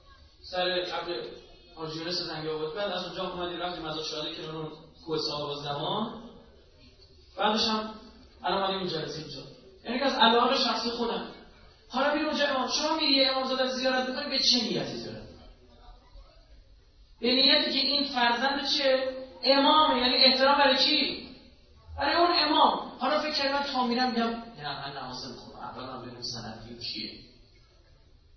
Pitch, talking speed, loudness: 225 Hz, 155 wpm, -26 LUFS